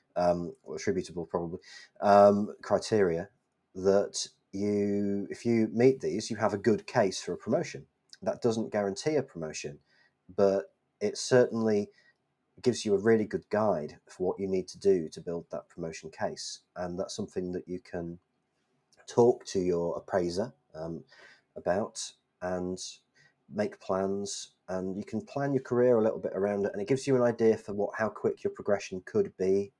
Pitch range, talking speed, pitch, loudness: 95-120 Hz, 170 wpm, 100 Hz, -30 LUFS